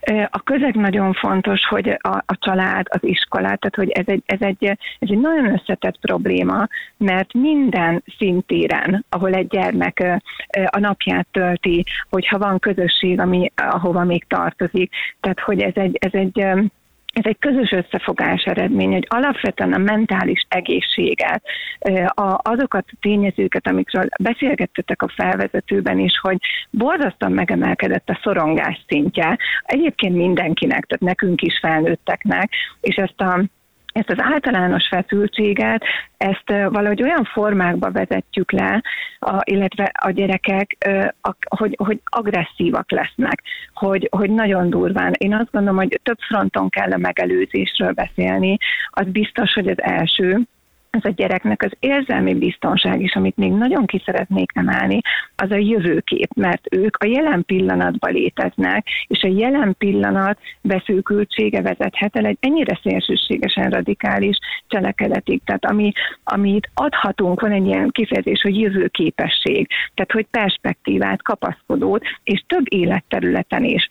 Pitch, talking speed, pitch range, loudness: 200 Hz, 135 wpm, 185-215 Hz, -18 LUFS